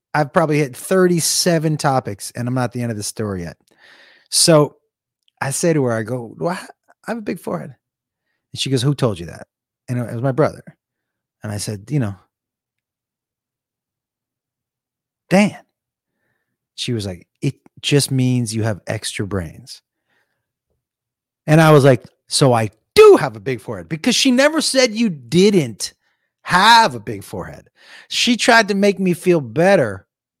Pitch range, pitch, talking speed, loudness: 120-175 Hz, 135 Hz, 165 wpm, -16 LUFS